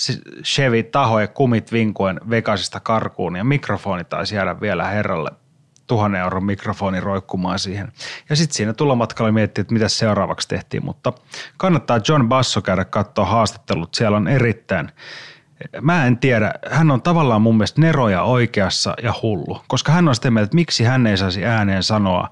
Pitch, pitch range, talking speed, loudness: 110 Hz, 100-130 Hz, 160 wpm, -18 LUFS